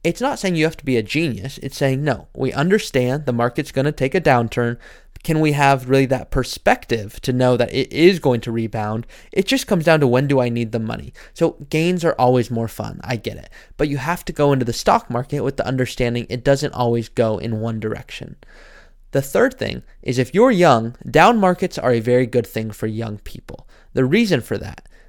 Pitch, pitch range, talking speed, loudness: 130 Hz, 115-155 Hz, 225 wpm, -19 LUFS